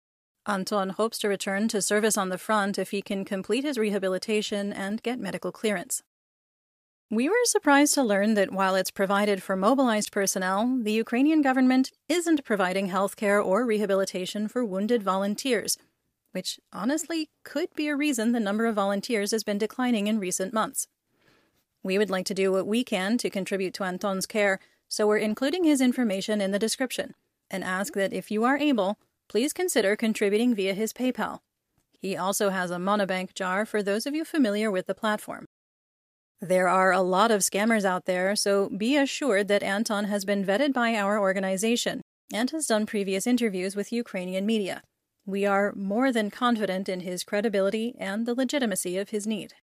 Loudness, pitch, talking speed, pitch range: -26 LUFS, 205 Hz, 180 wpm, 195-235 Hz